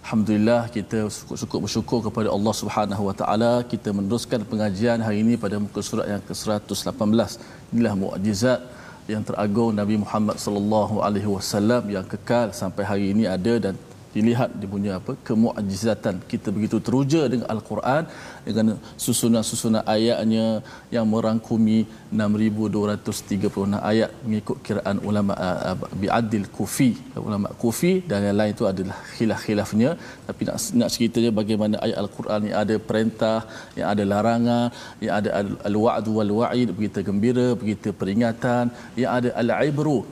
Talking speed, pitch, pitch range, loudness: 140 wpm, 110 Hz, 105-115 Hz, -23 LUFS